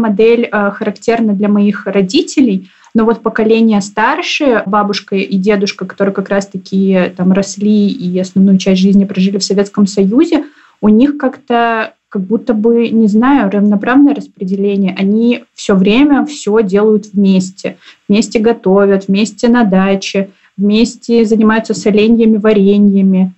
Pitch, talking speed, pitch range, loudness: 210 Hz, 130 wpm, 195-230 Hz, -11 LUFS